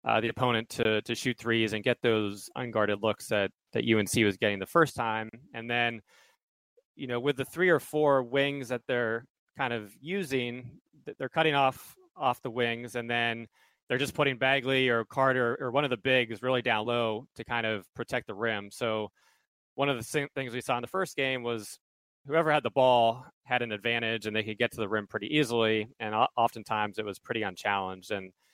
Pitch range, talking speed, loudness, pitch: 110-130 Hz, 205 wpm, -29 LUFS, 120 Hz